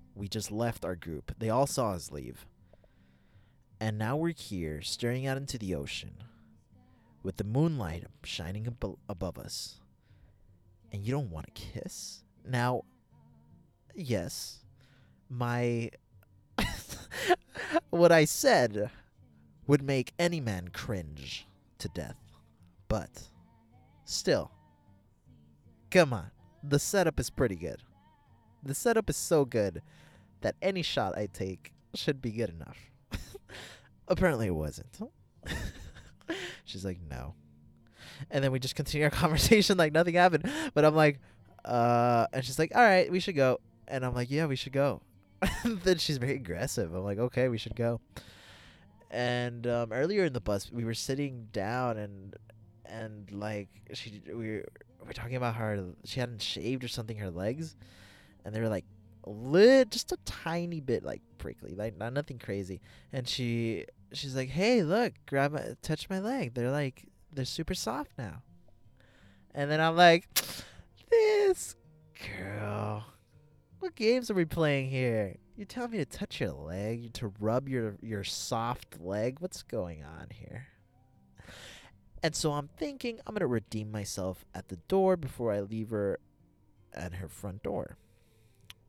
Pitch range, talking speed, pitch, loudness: 100-140 Hz, 150 wpm, 115 Hz, -31 LUFS